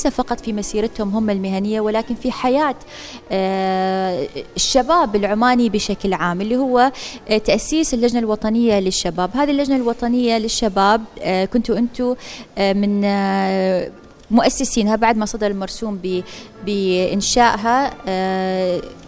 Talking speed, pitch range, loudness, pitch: 100 wpm, 195-240 Hz, -18 LUFS, 215 Hz